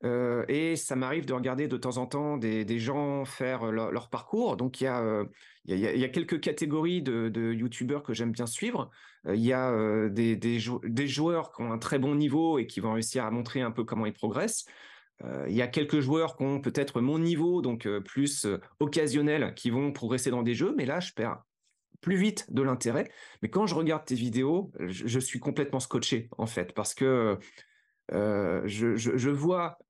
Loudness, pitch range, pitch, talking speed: -30 LUFS, 115-145 Hz, 130 Hz, 225 wpm